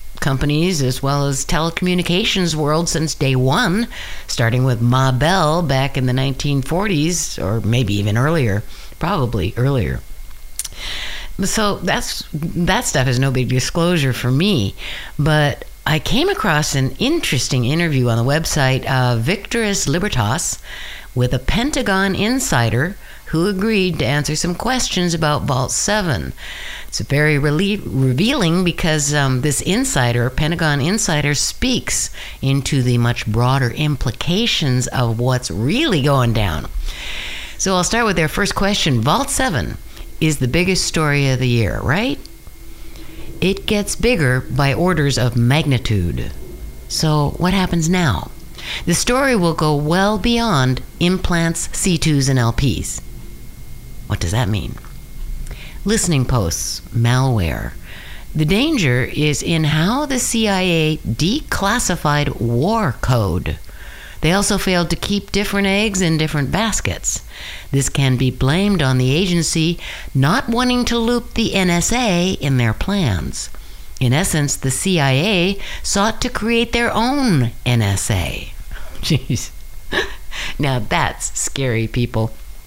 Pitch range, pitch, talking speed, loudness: 125-185 Hz, 150 Hz, 130 wpm, -17 LUFS